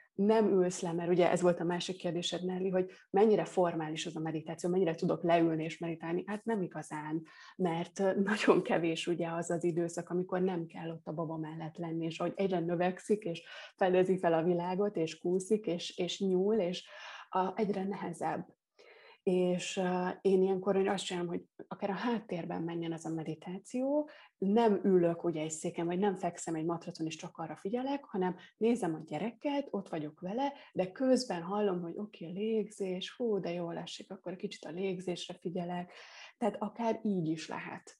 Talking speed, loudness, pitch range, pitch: 180 wpm, -34 LUFS, 170-200 Hz, 180 Hz